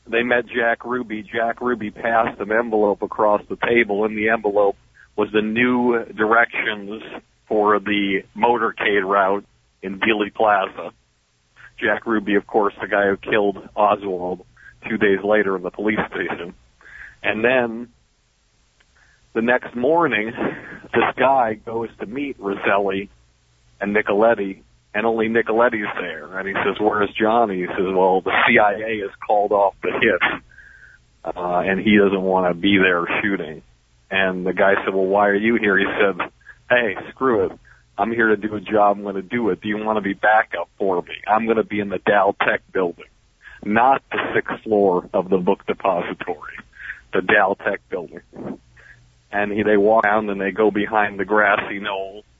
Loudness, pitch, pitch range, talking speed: -19 LUFS, 105 Hz, 95-110 Hz, 170 wpm